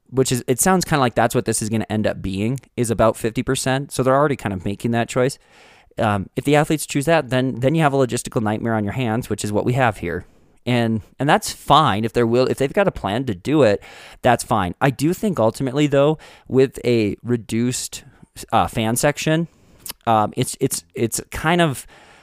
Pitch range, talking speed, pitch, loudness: 110-135 Hz, 225 wpm, 125 Hz, -20 LUFS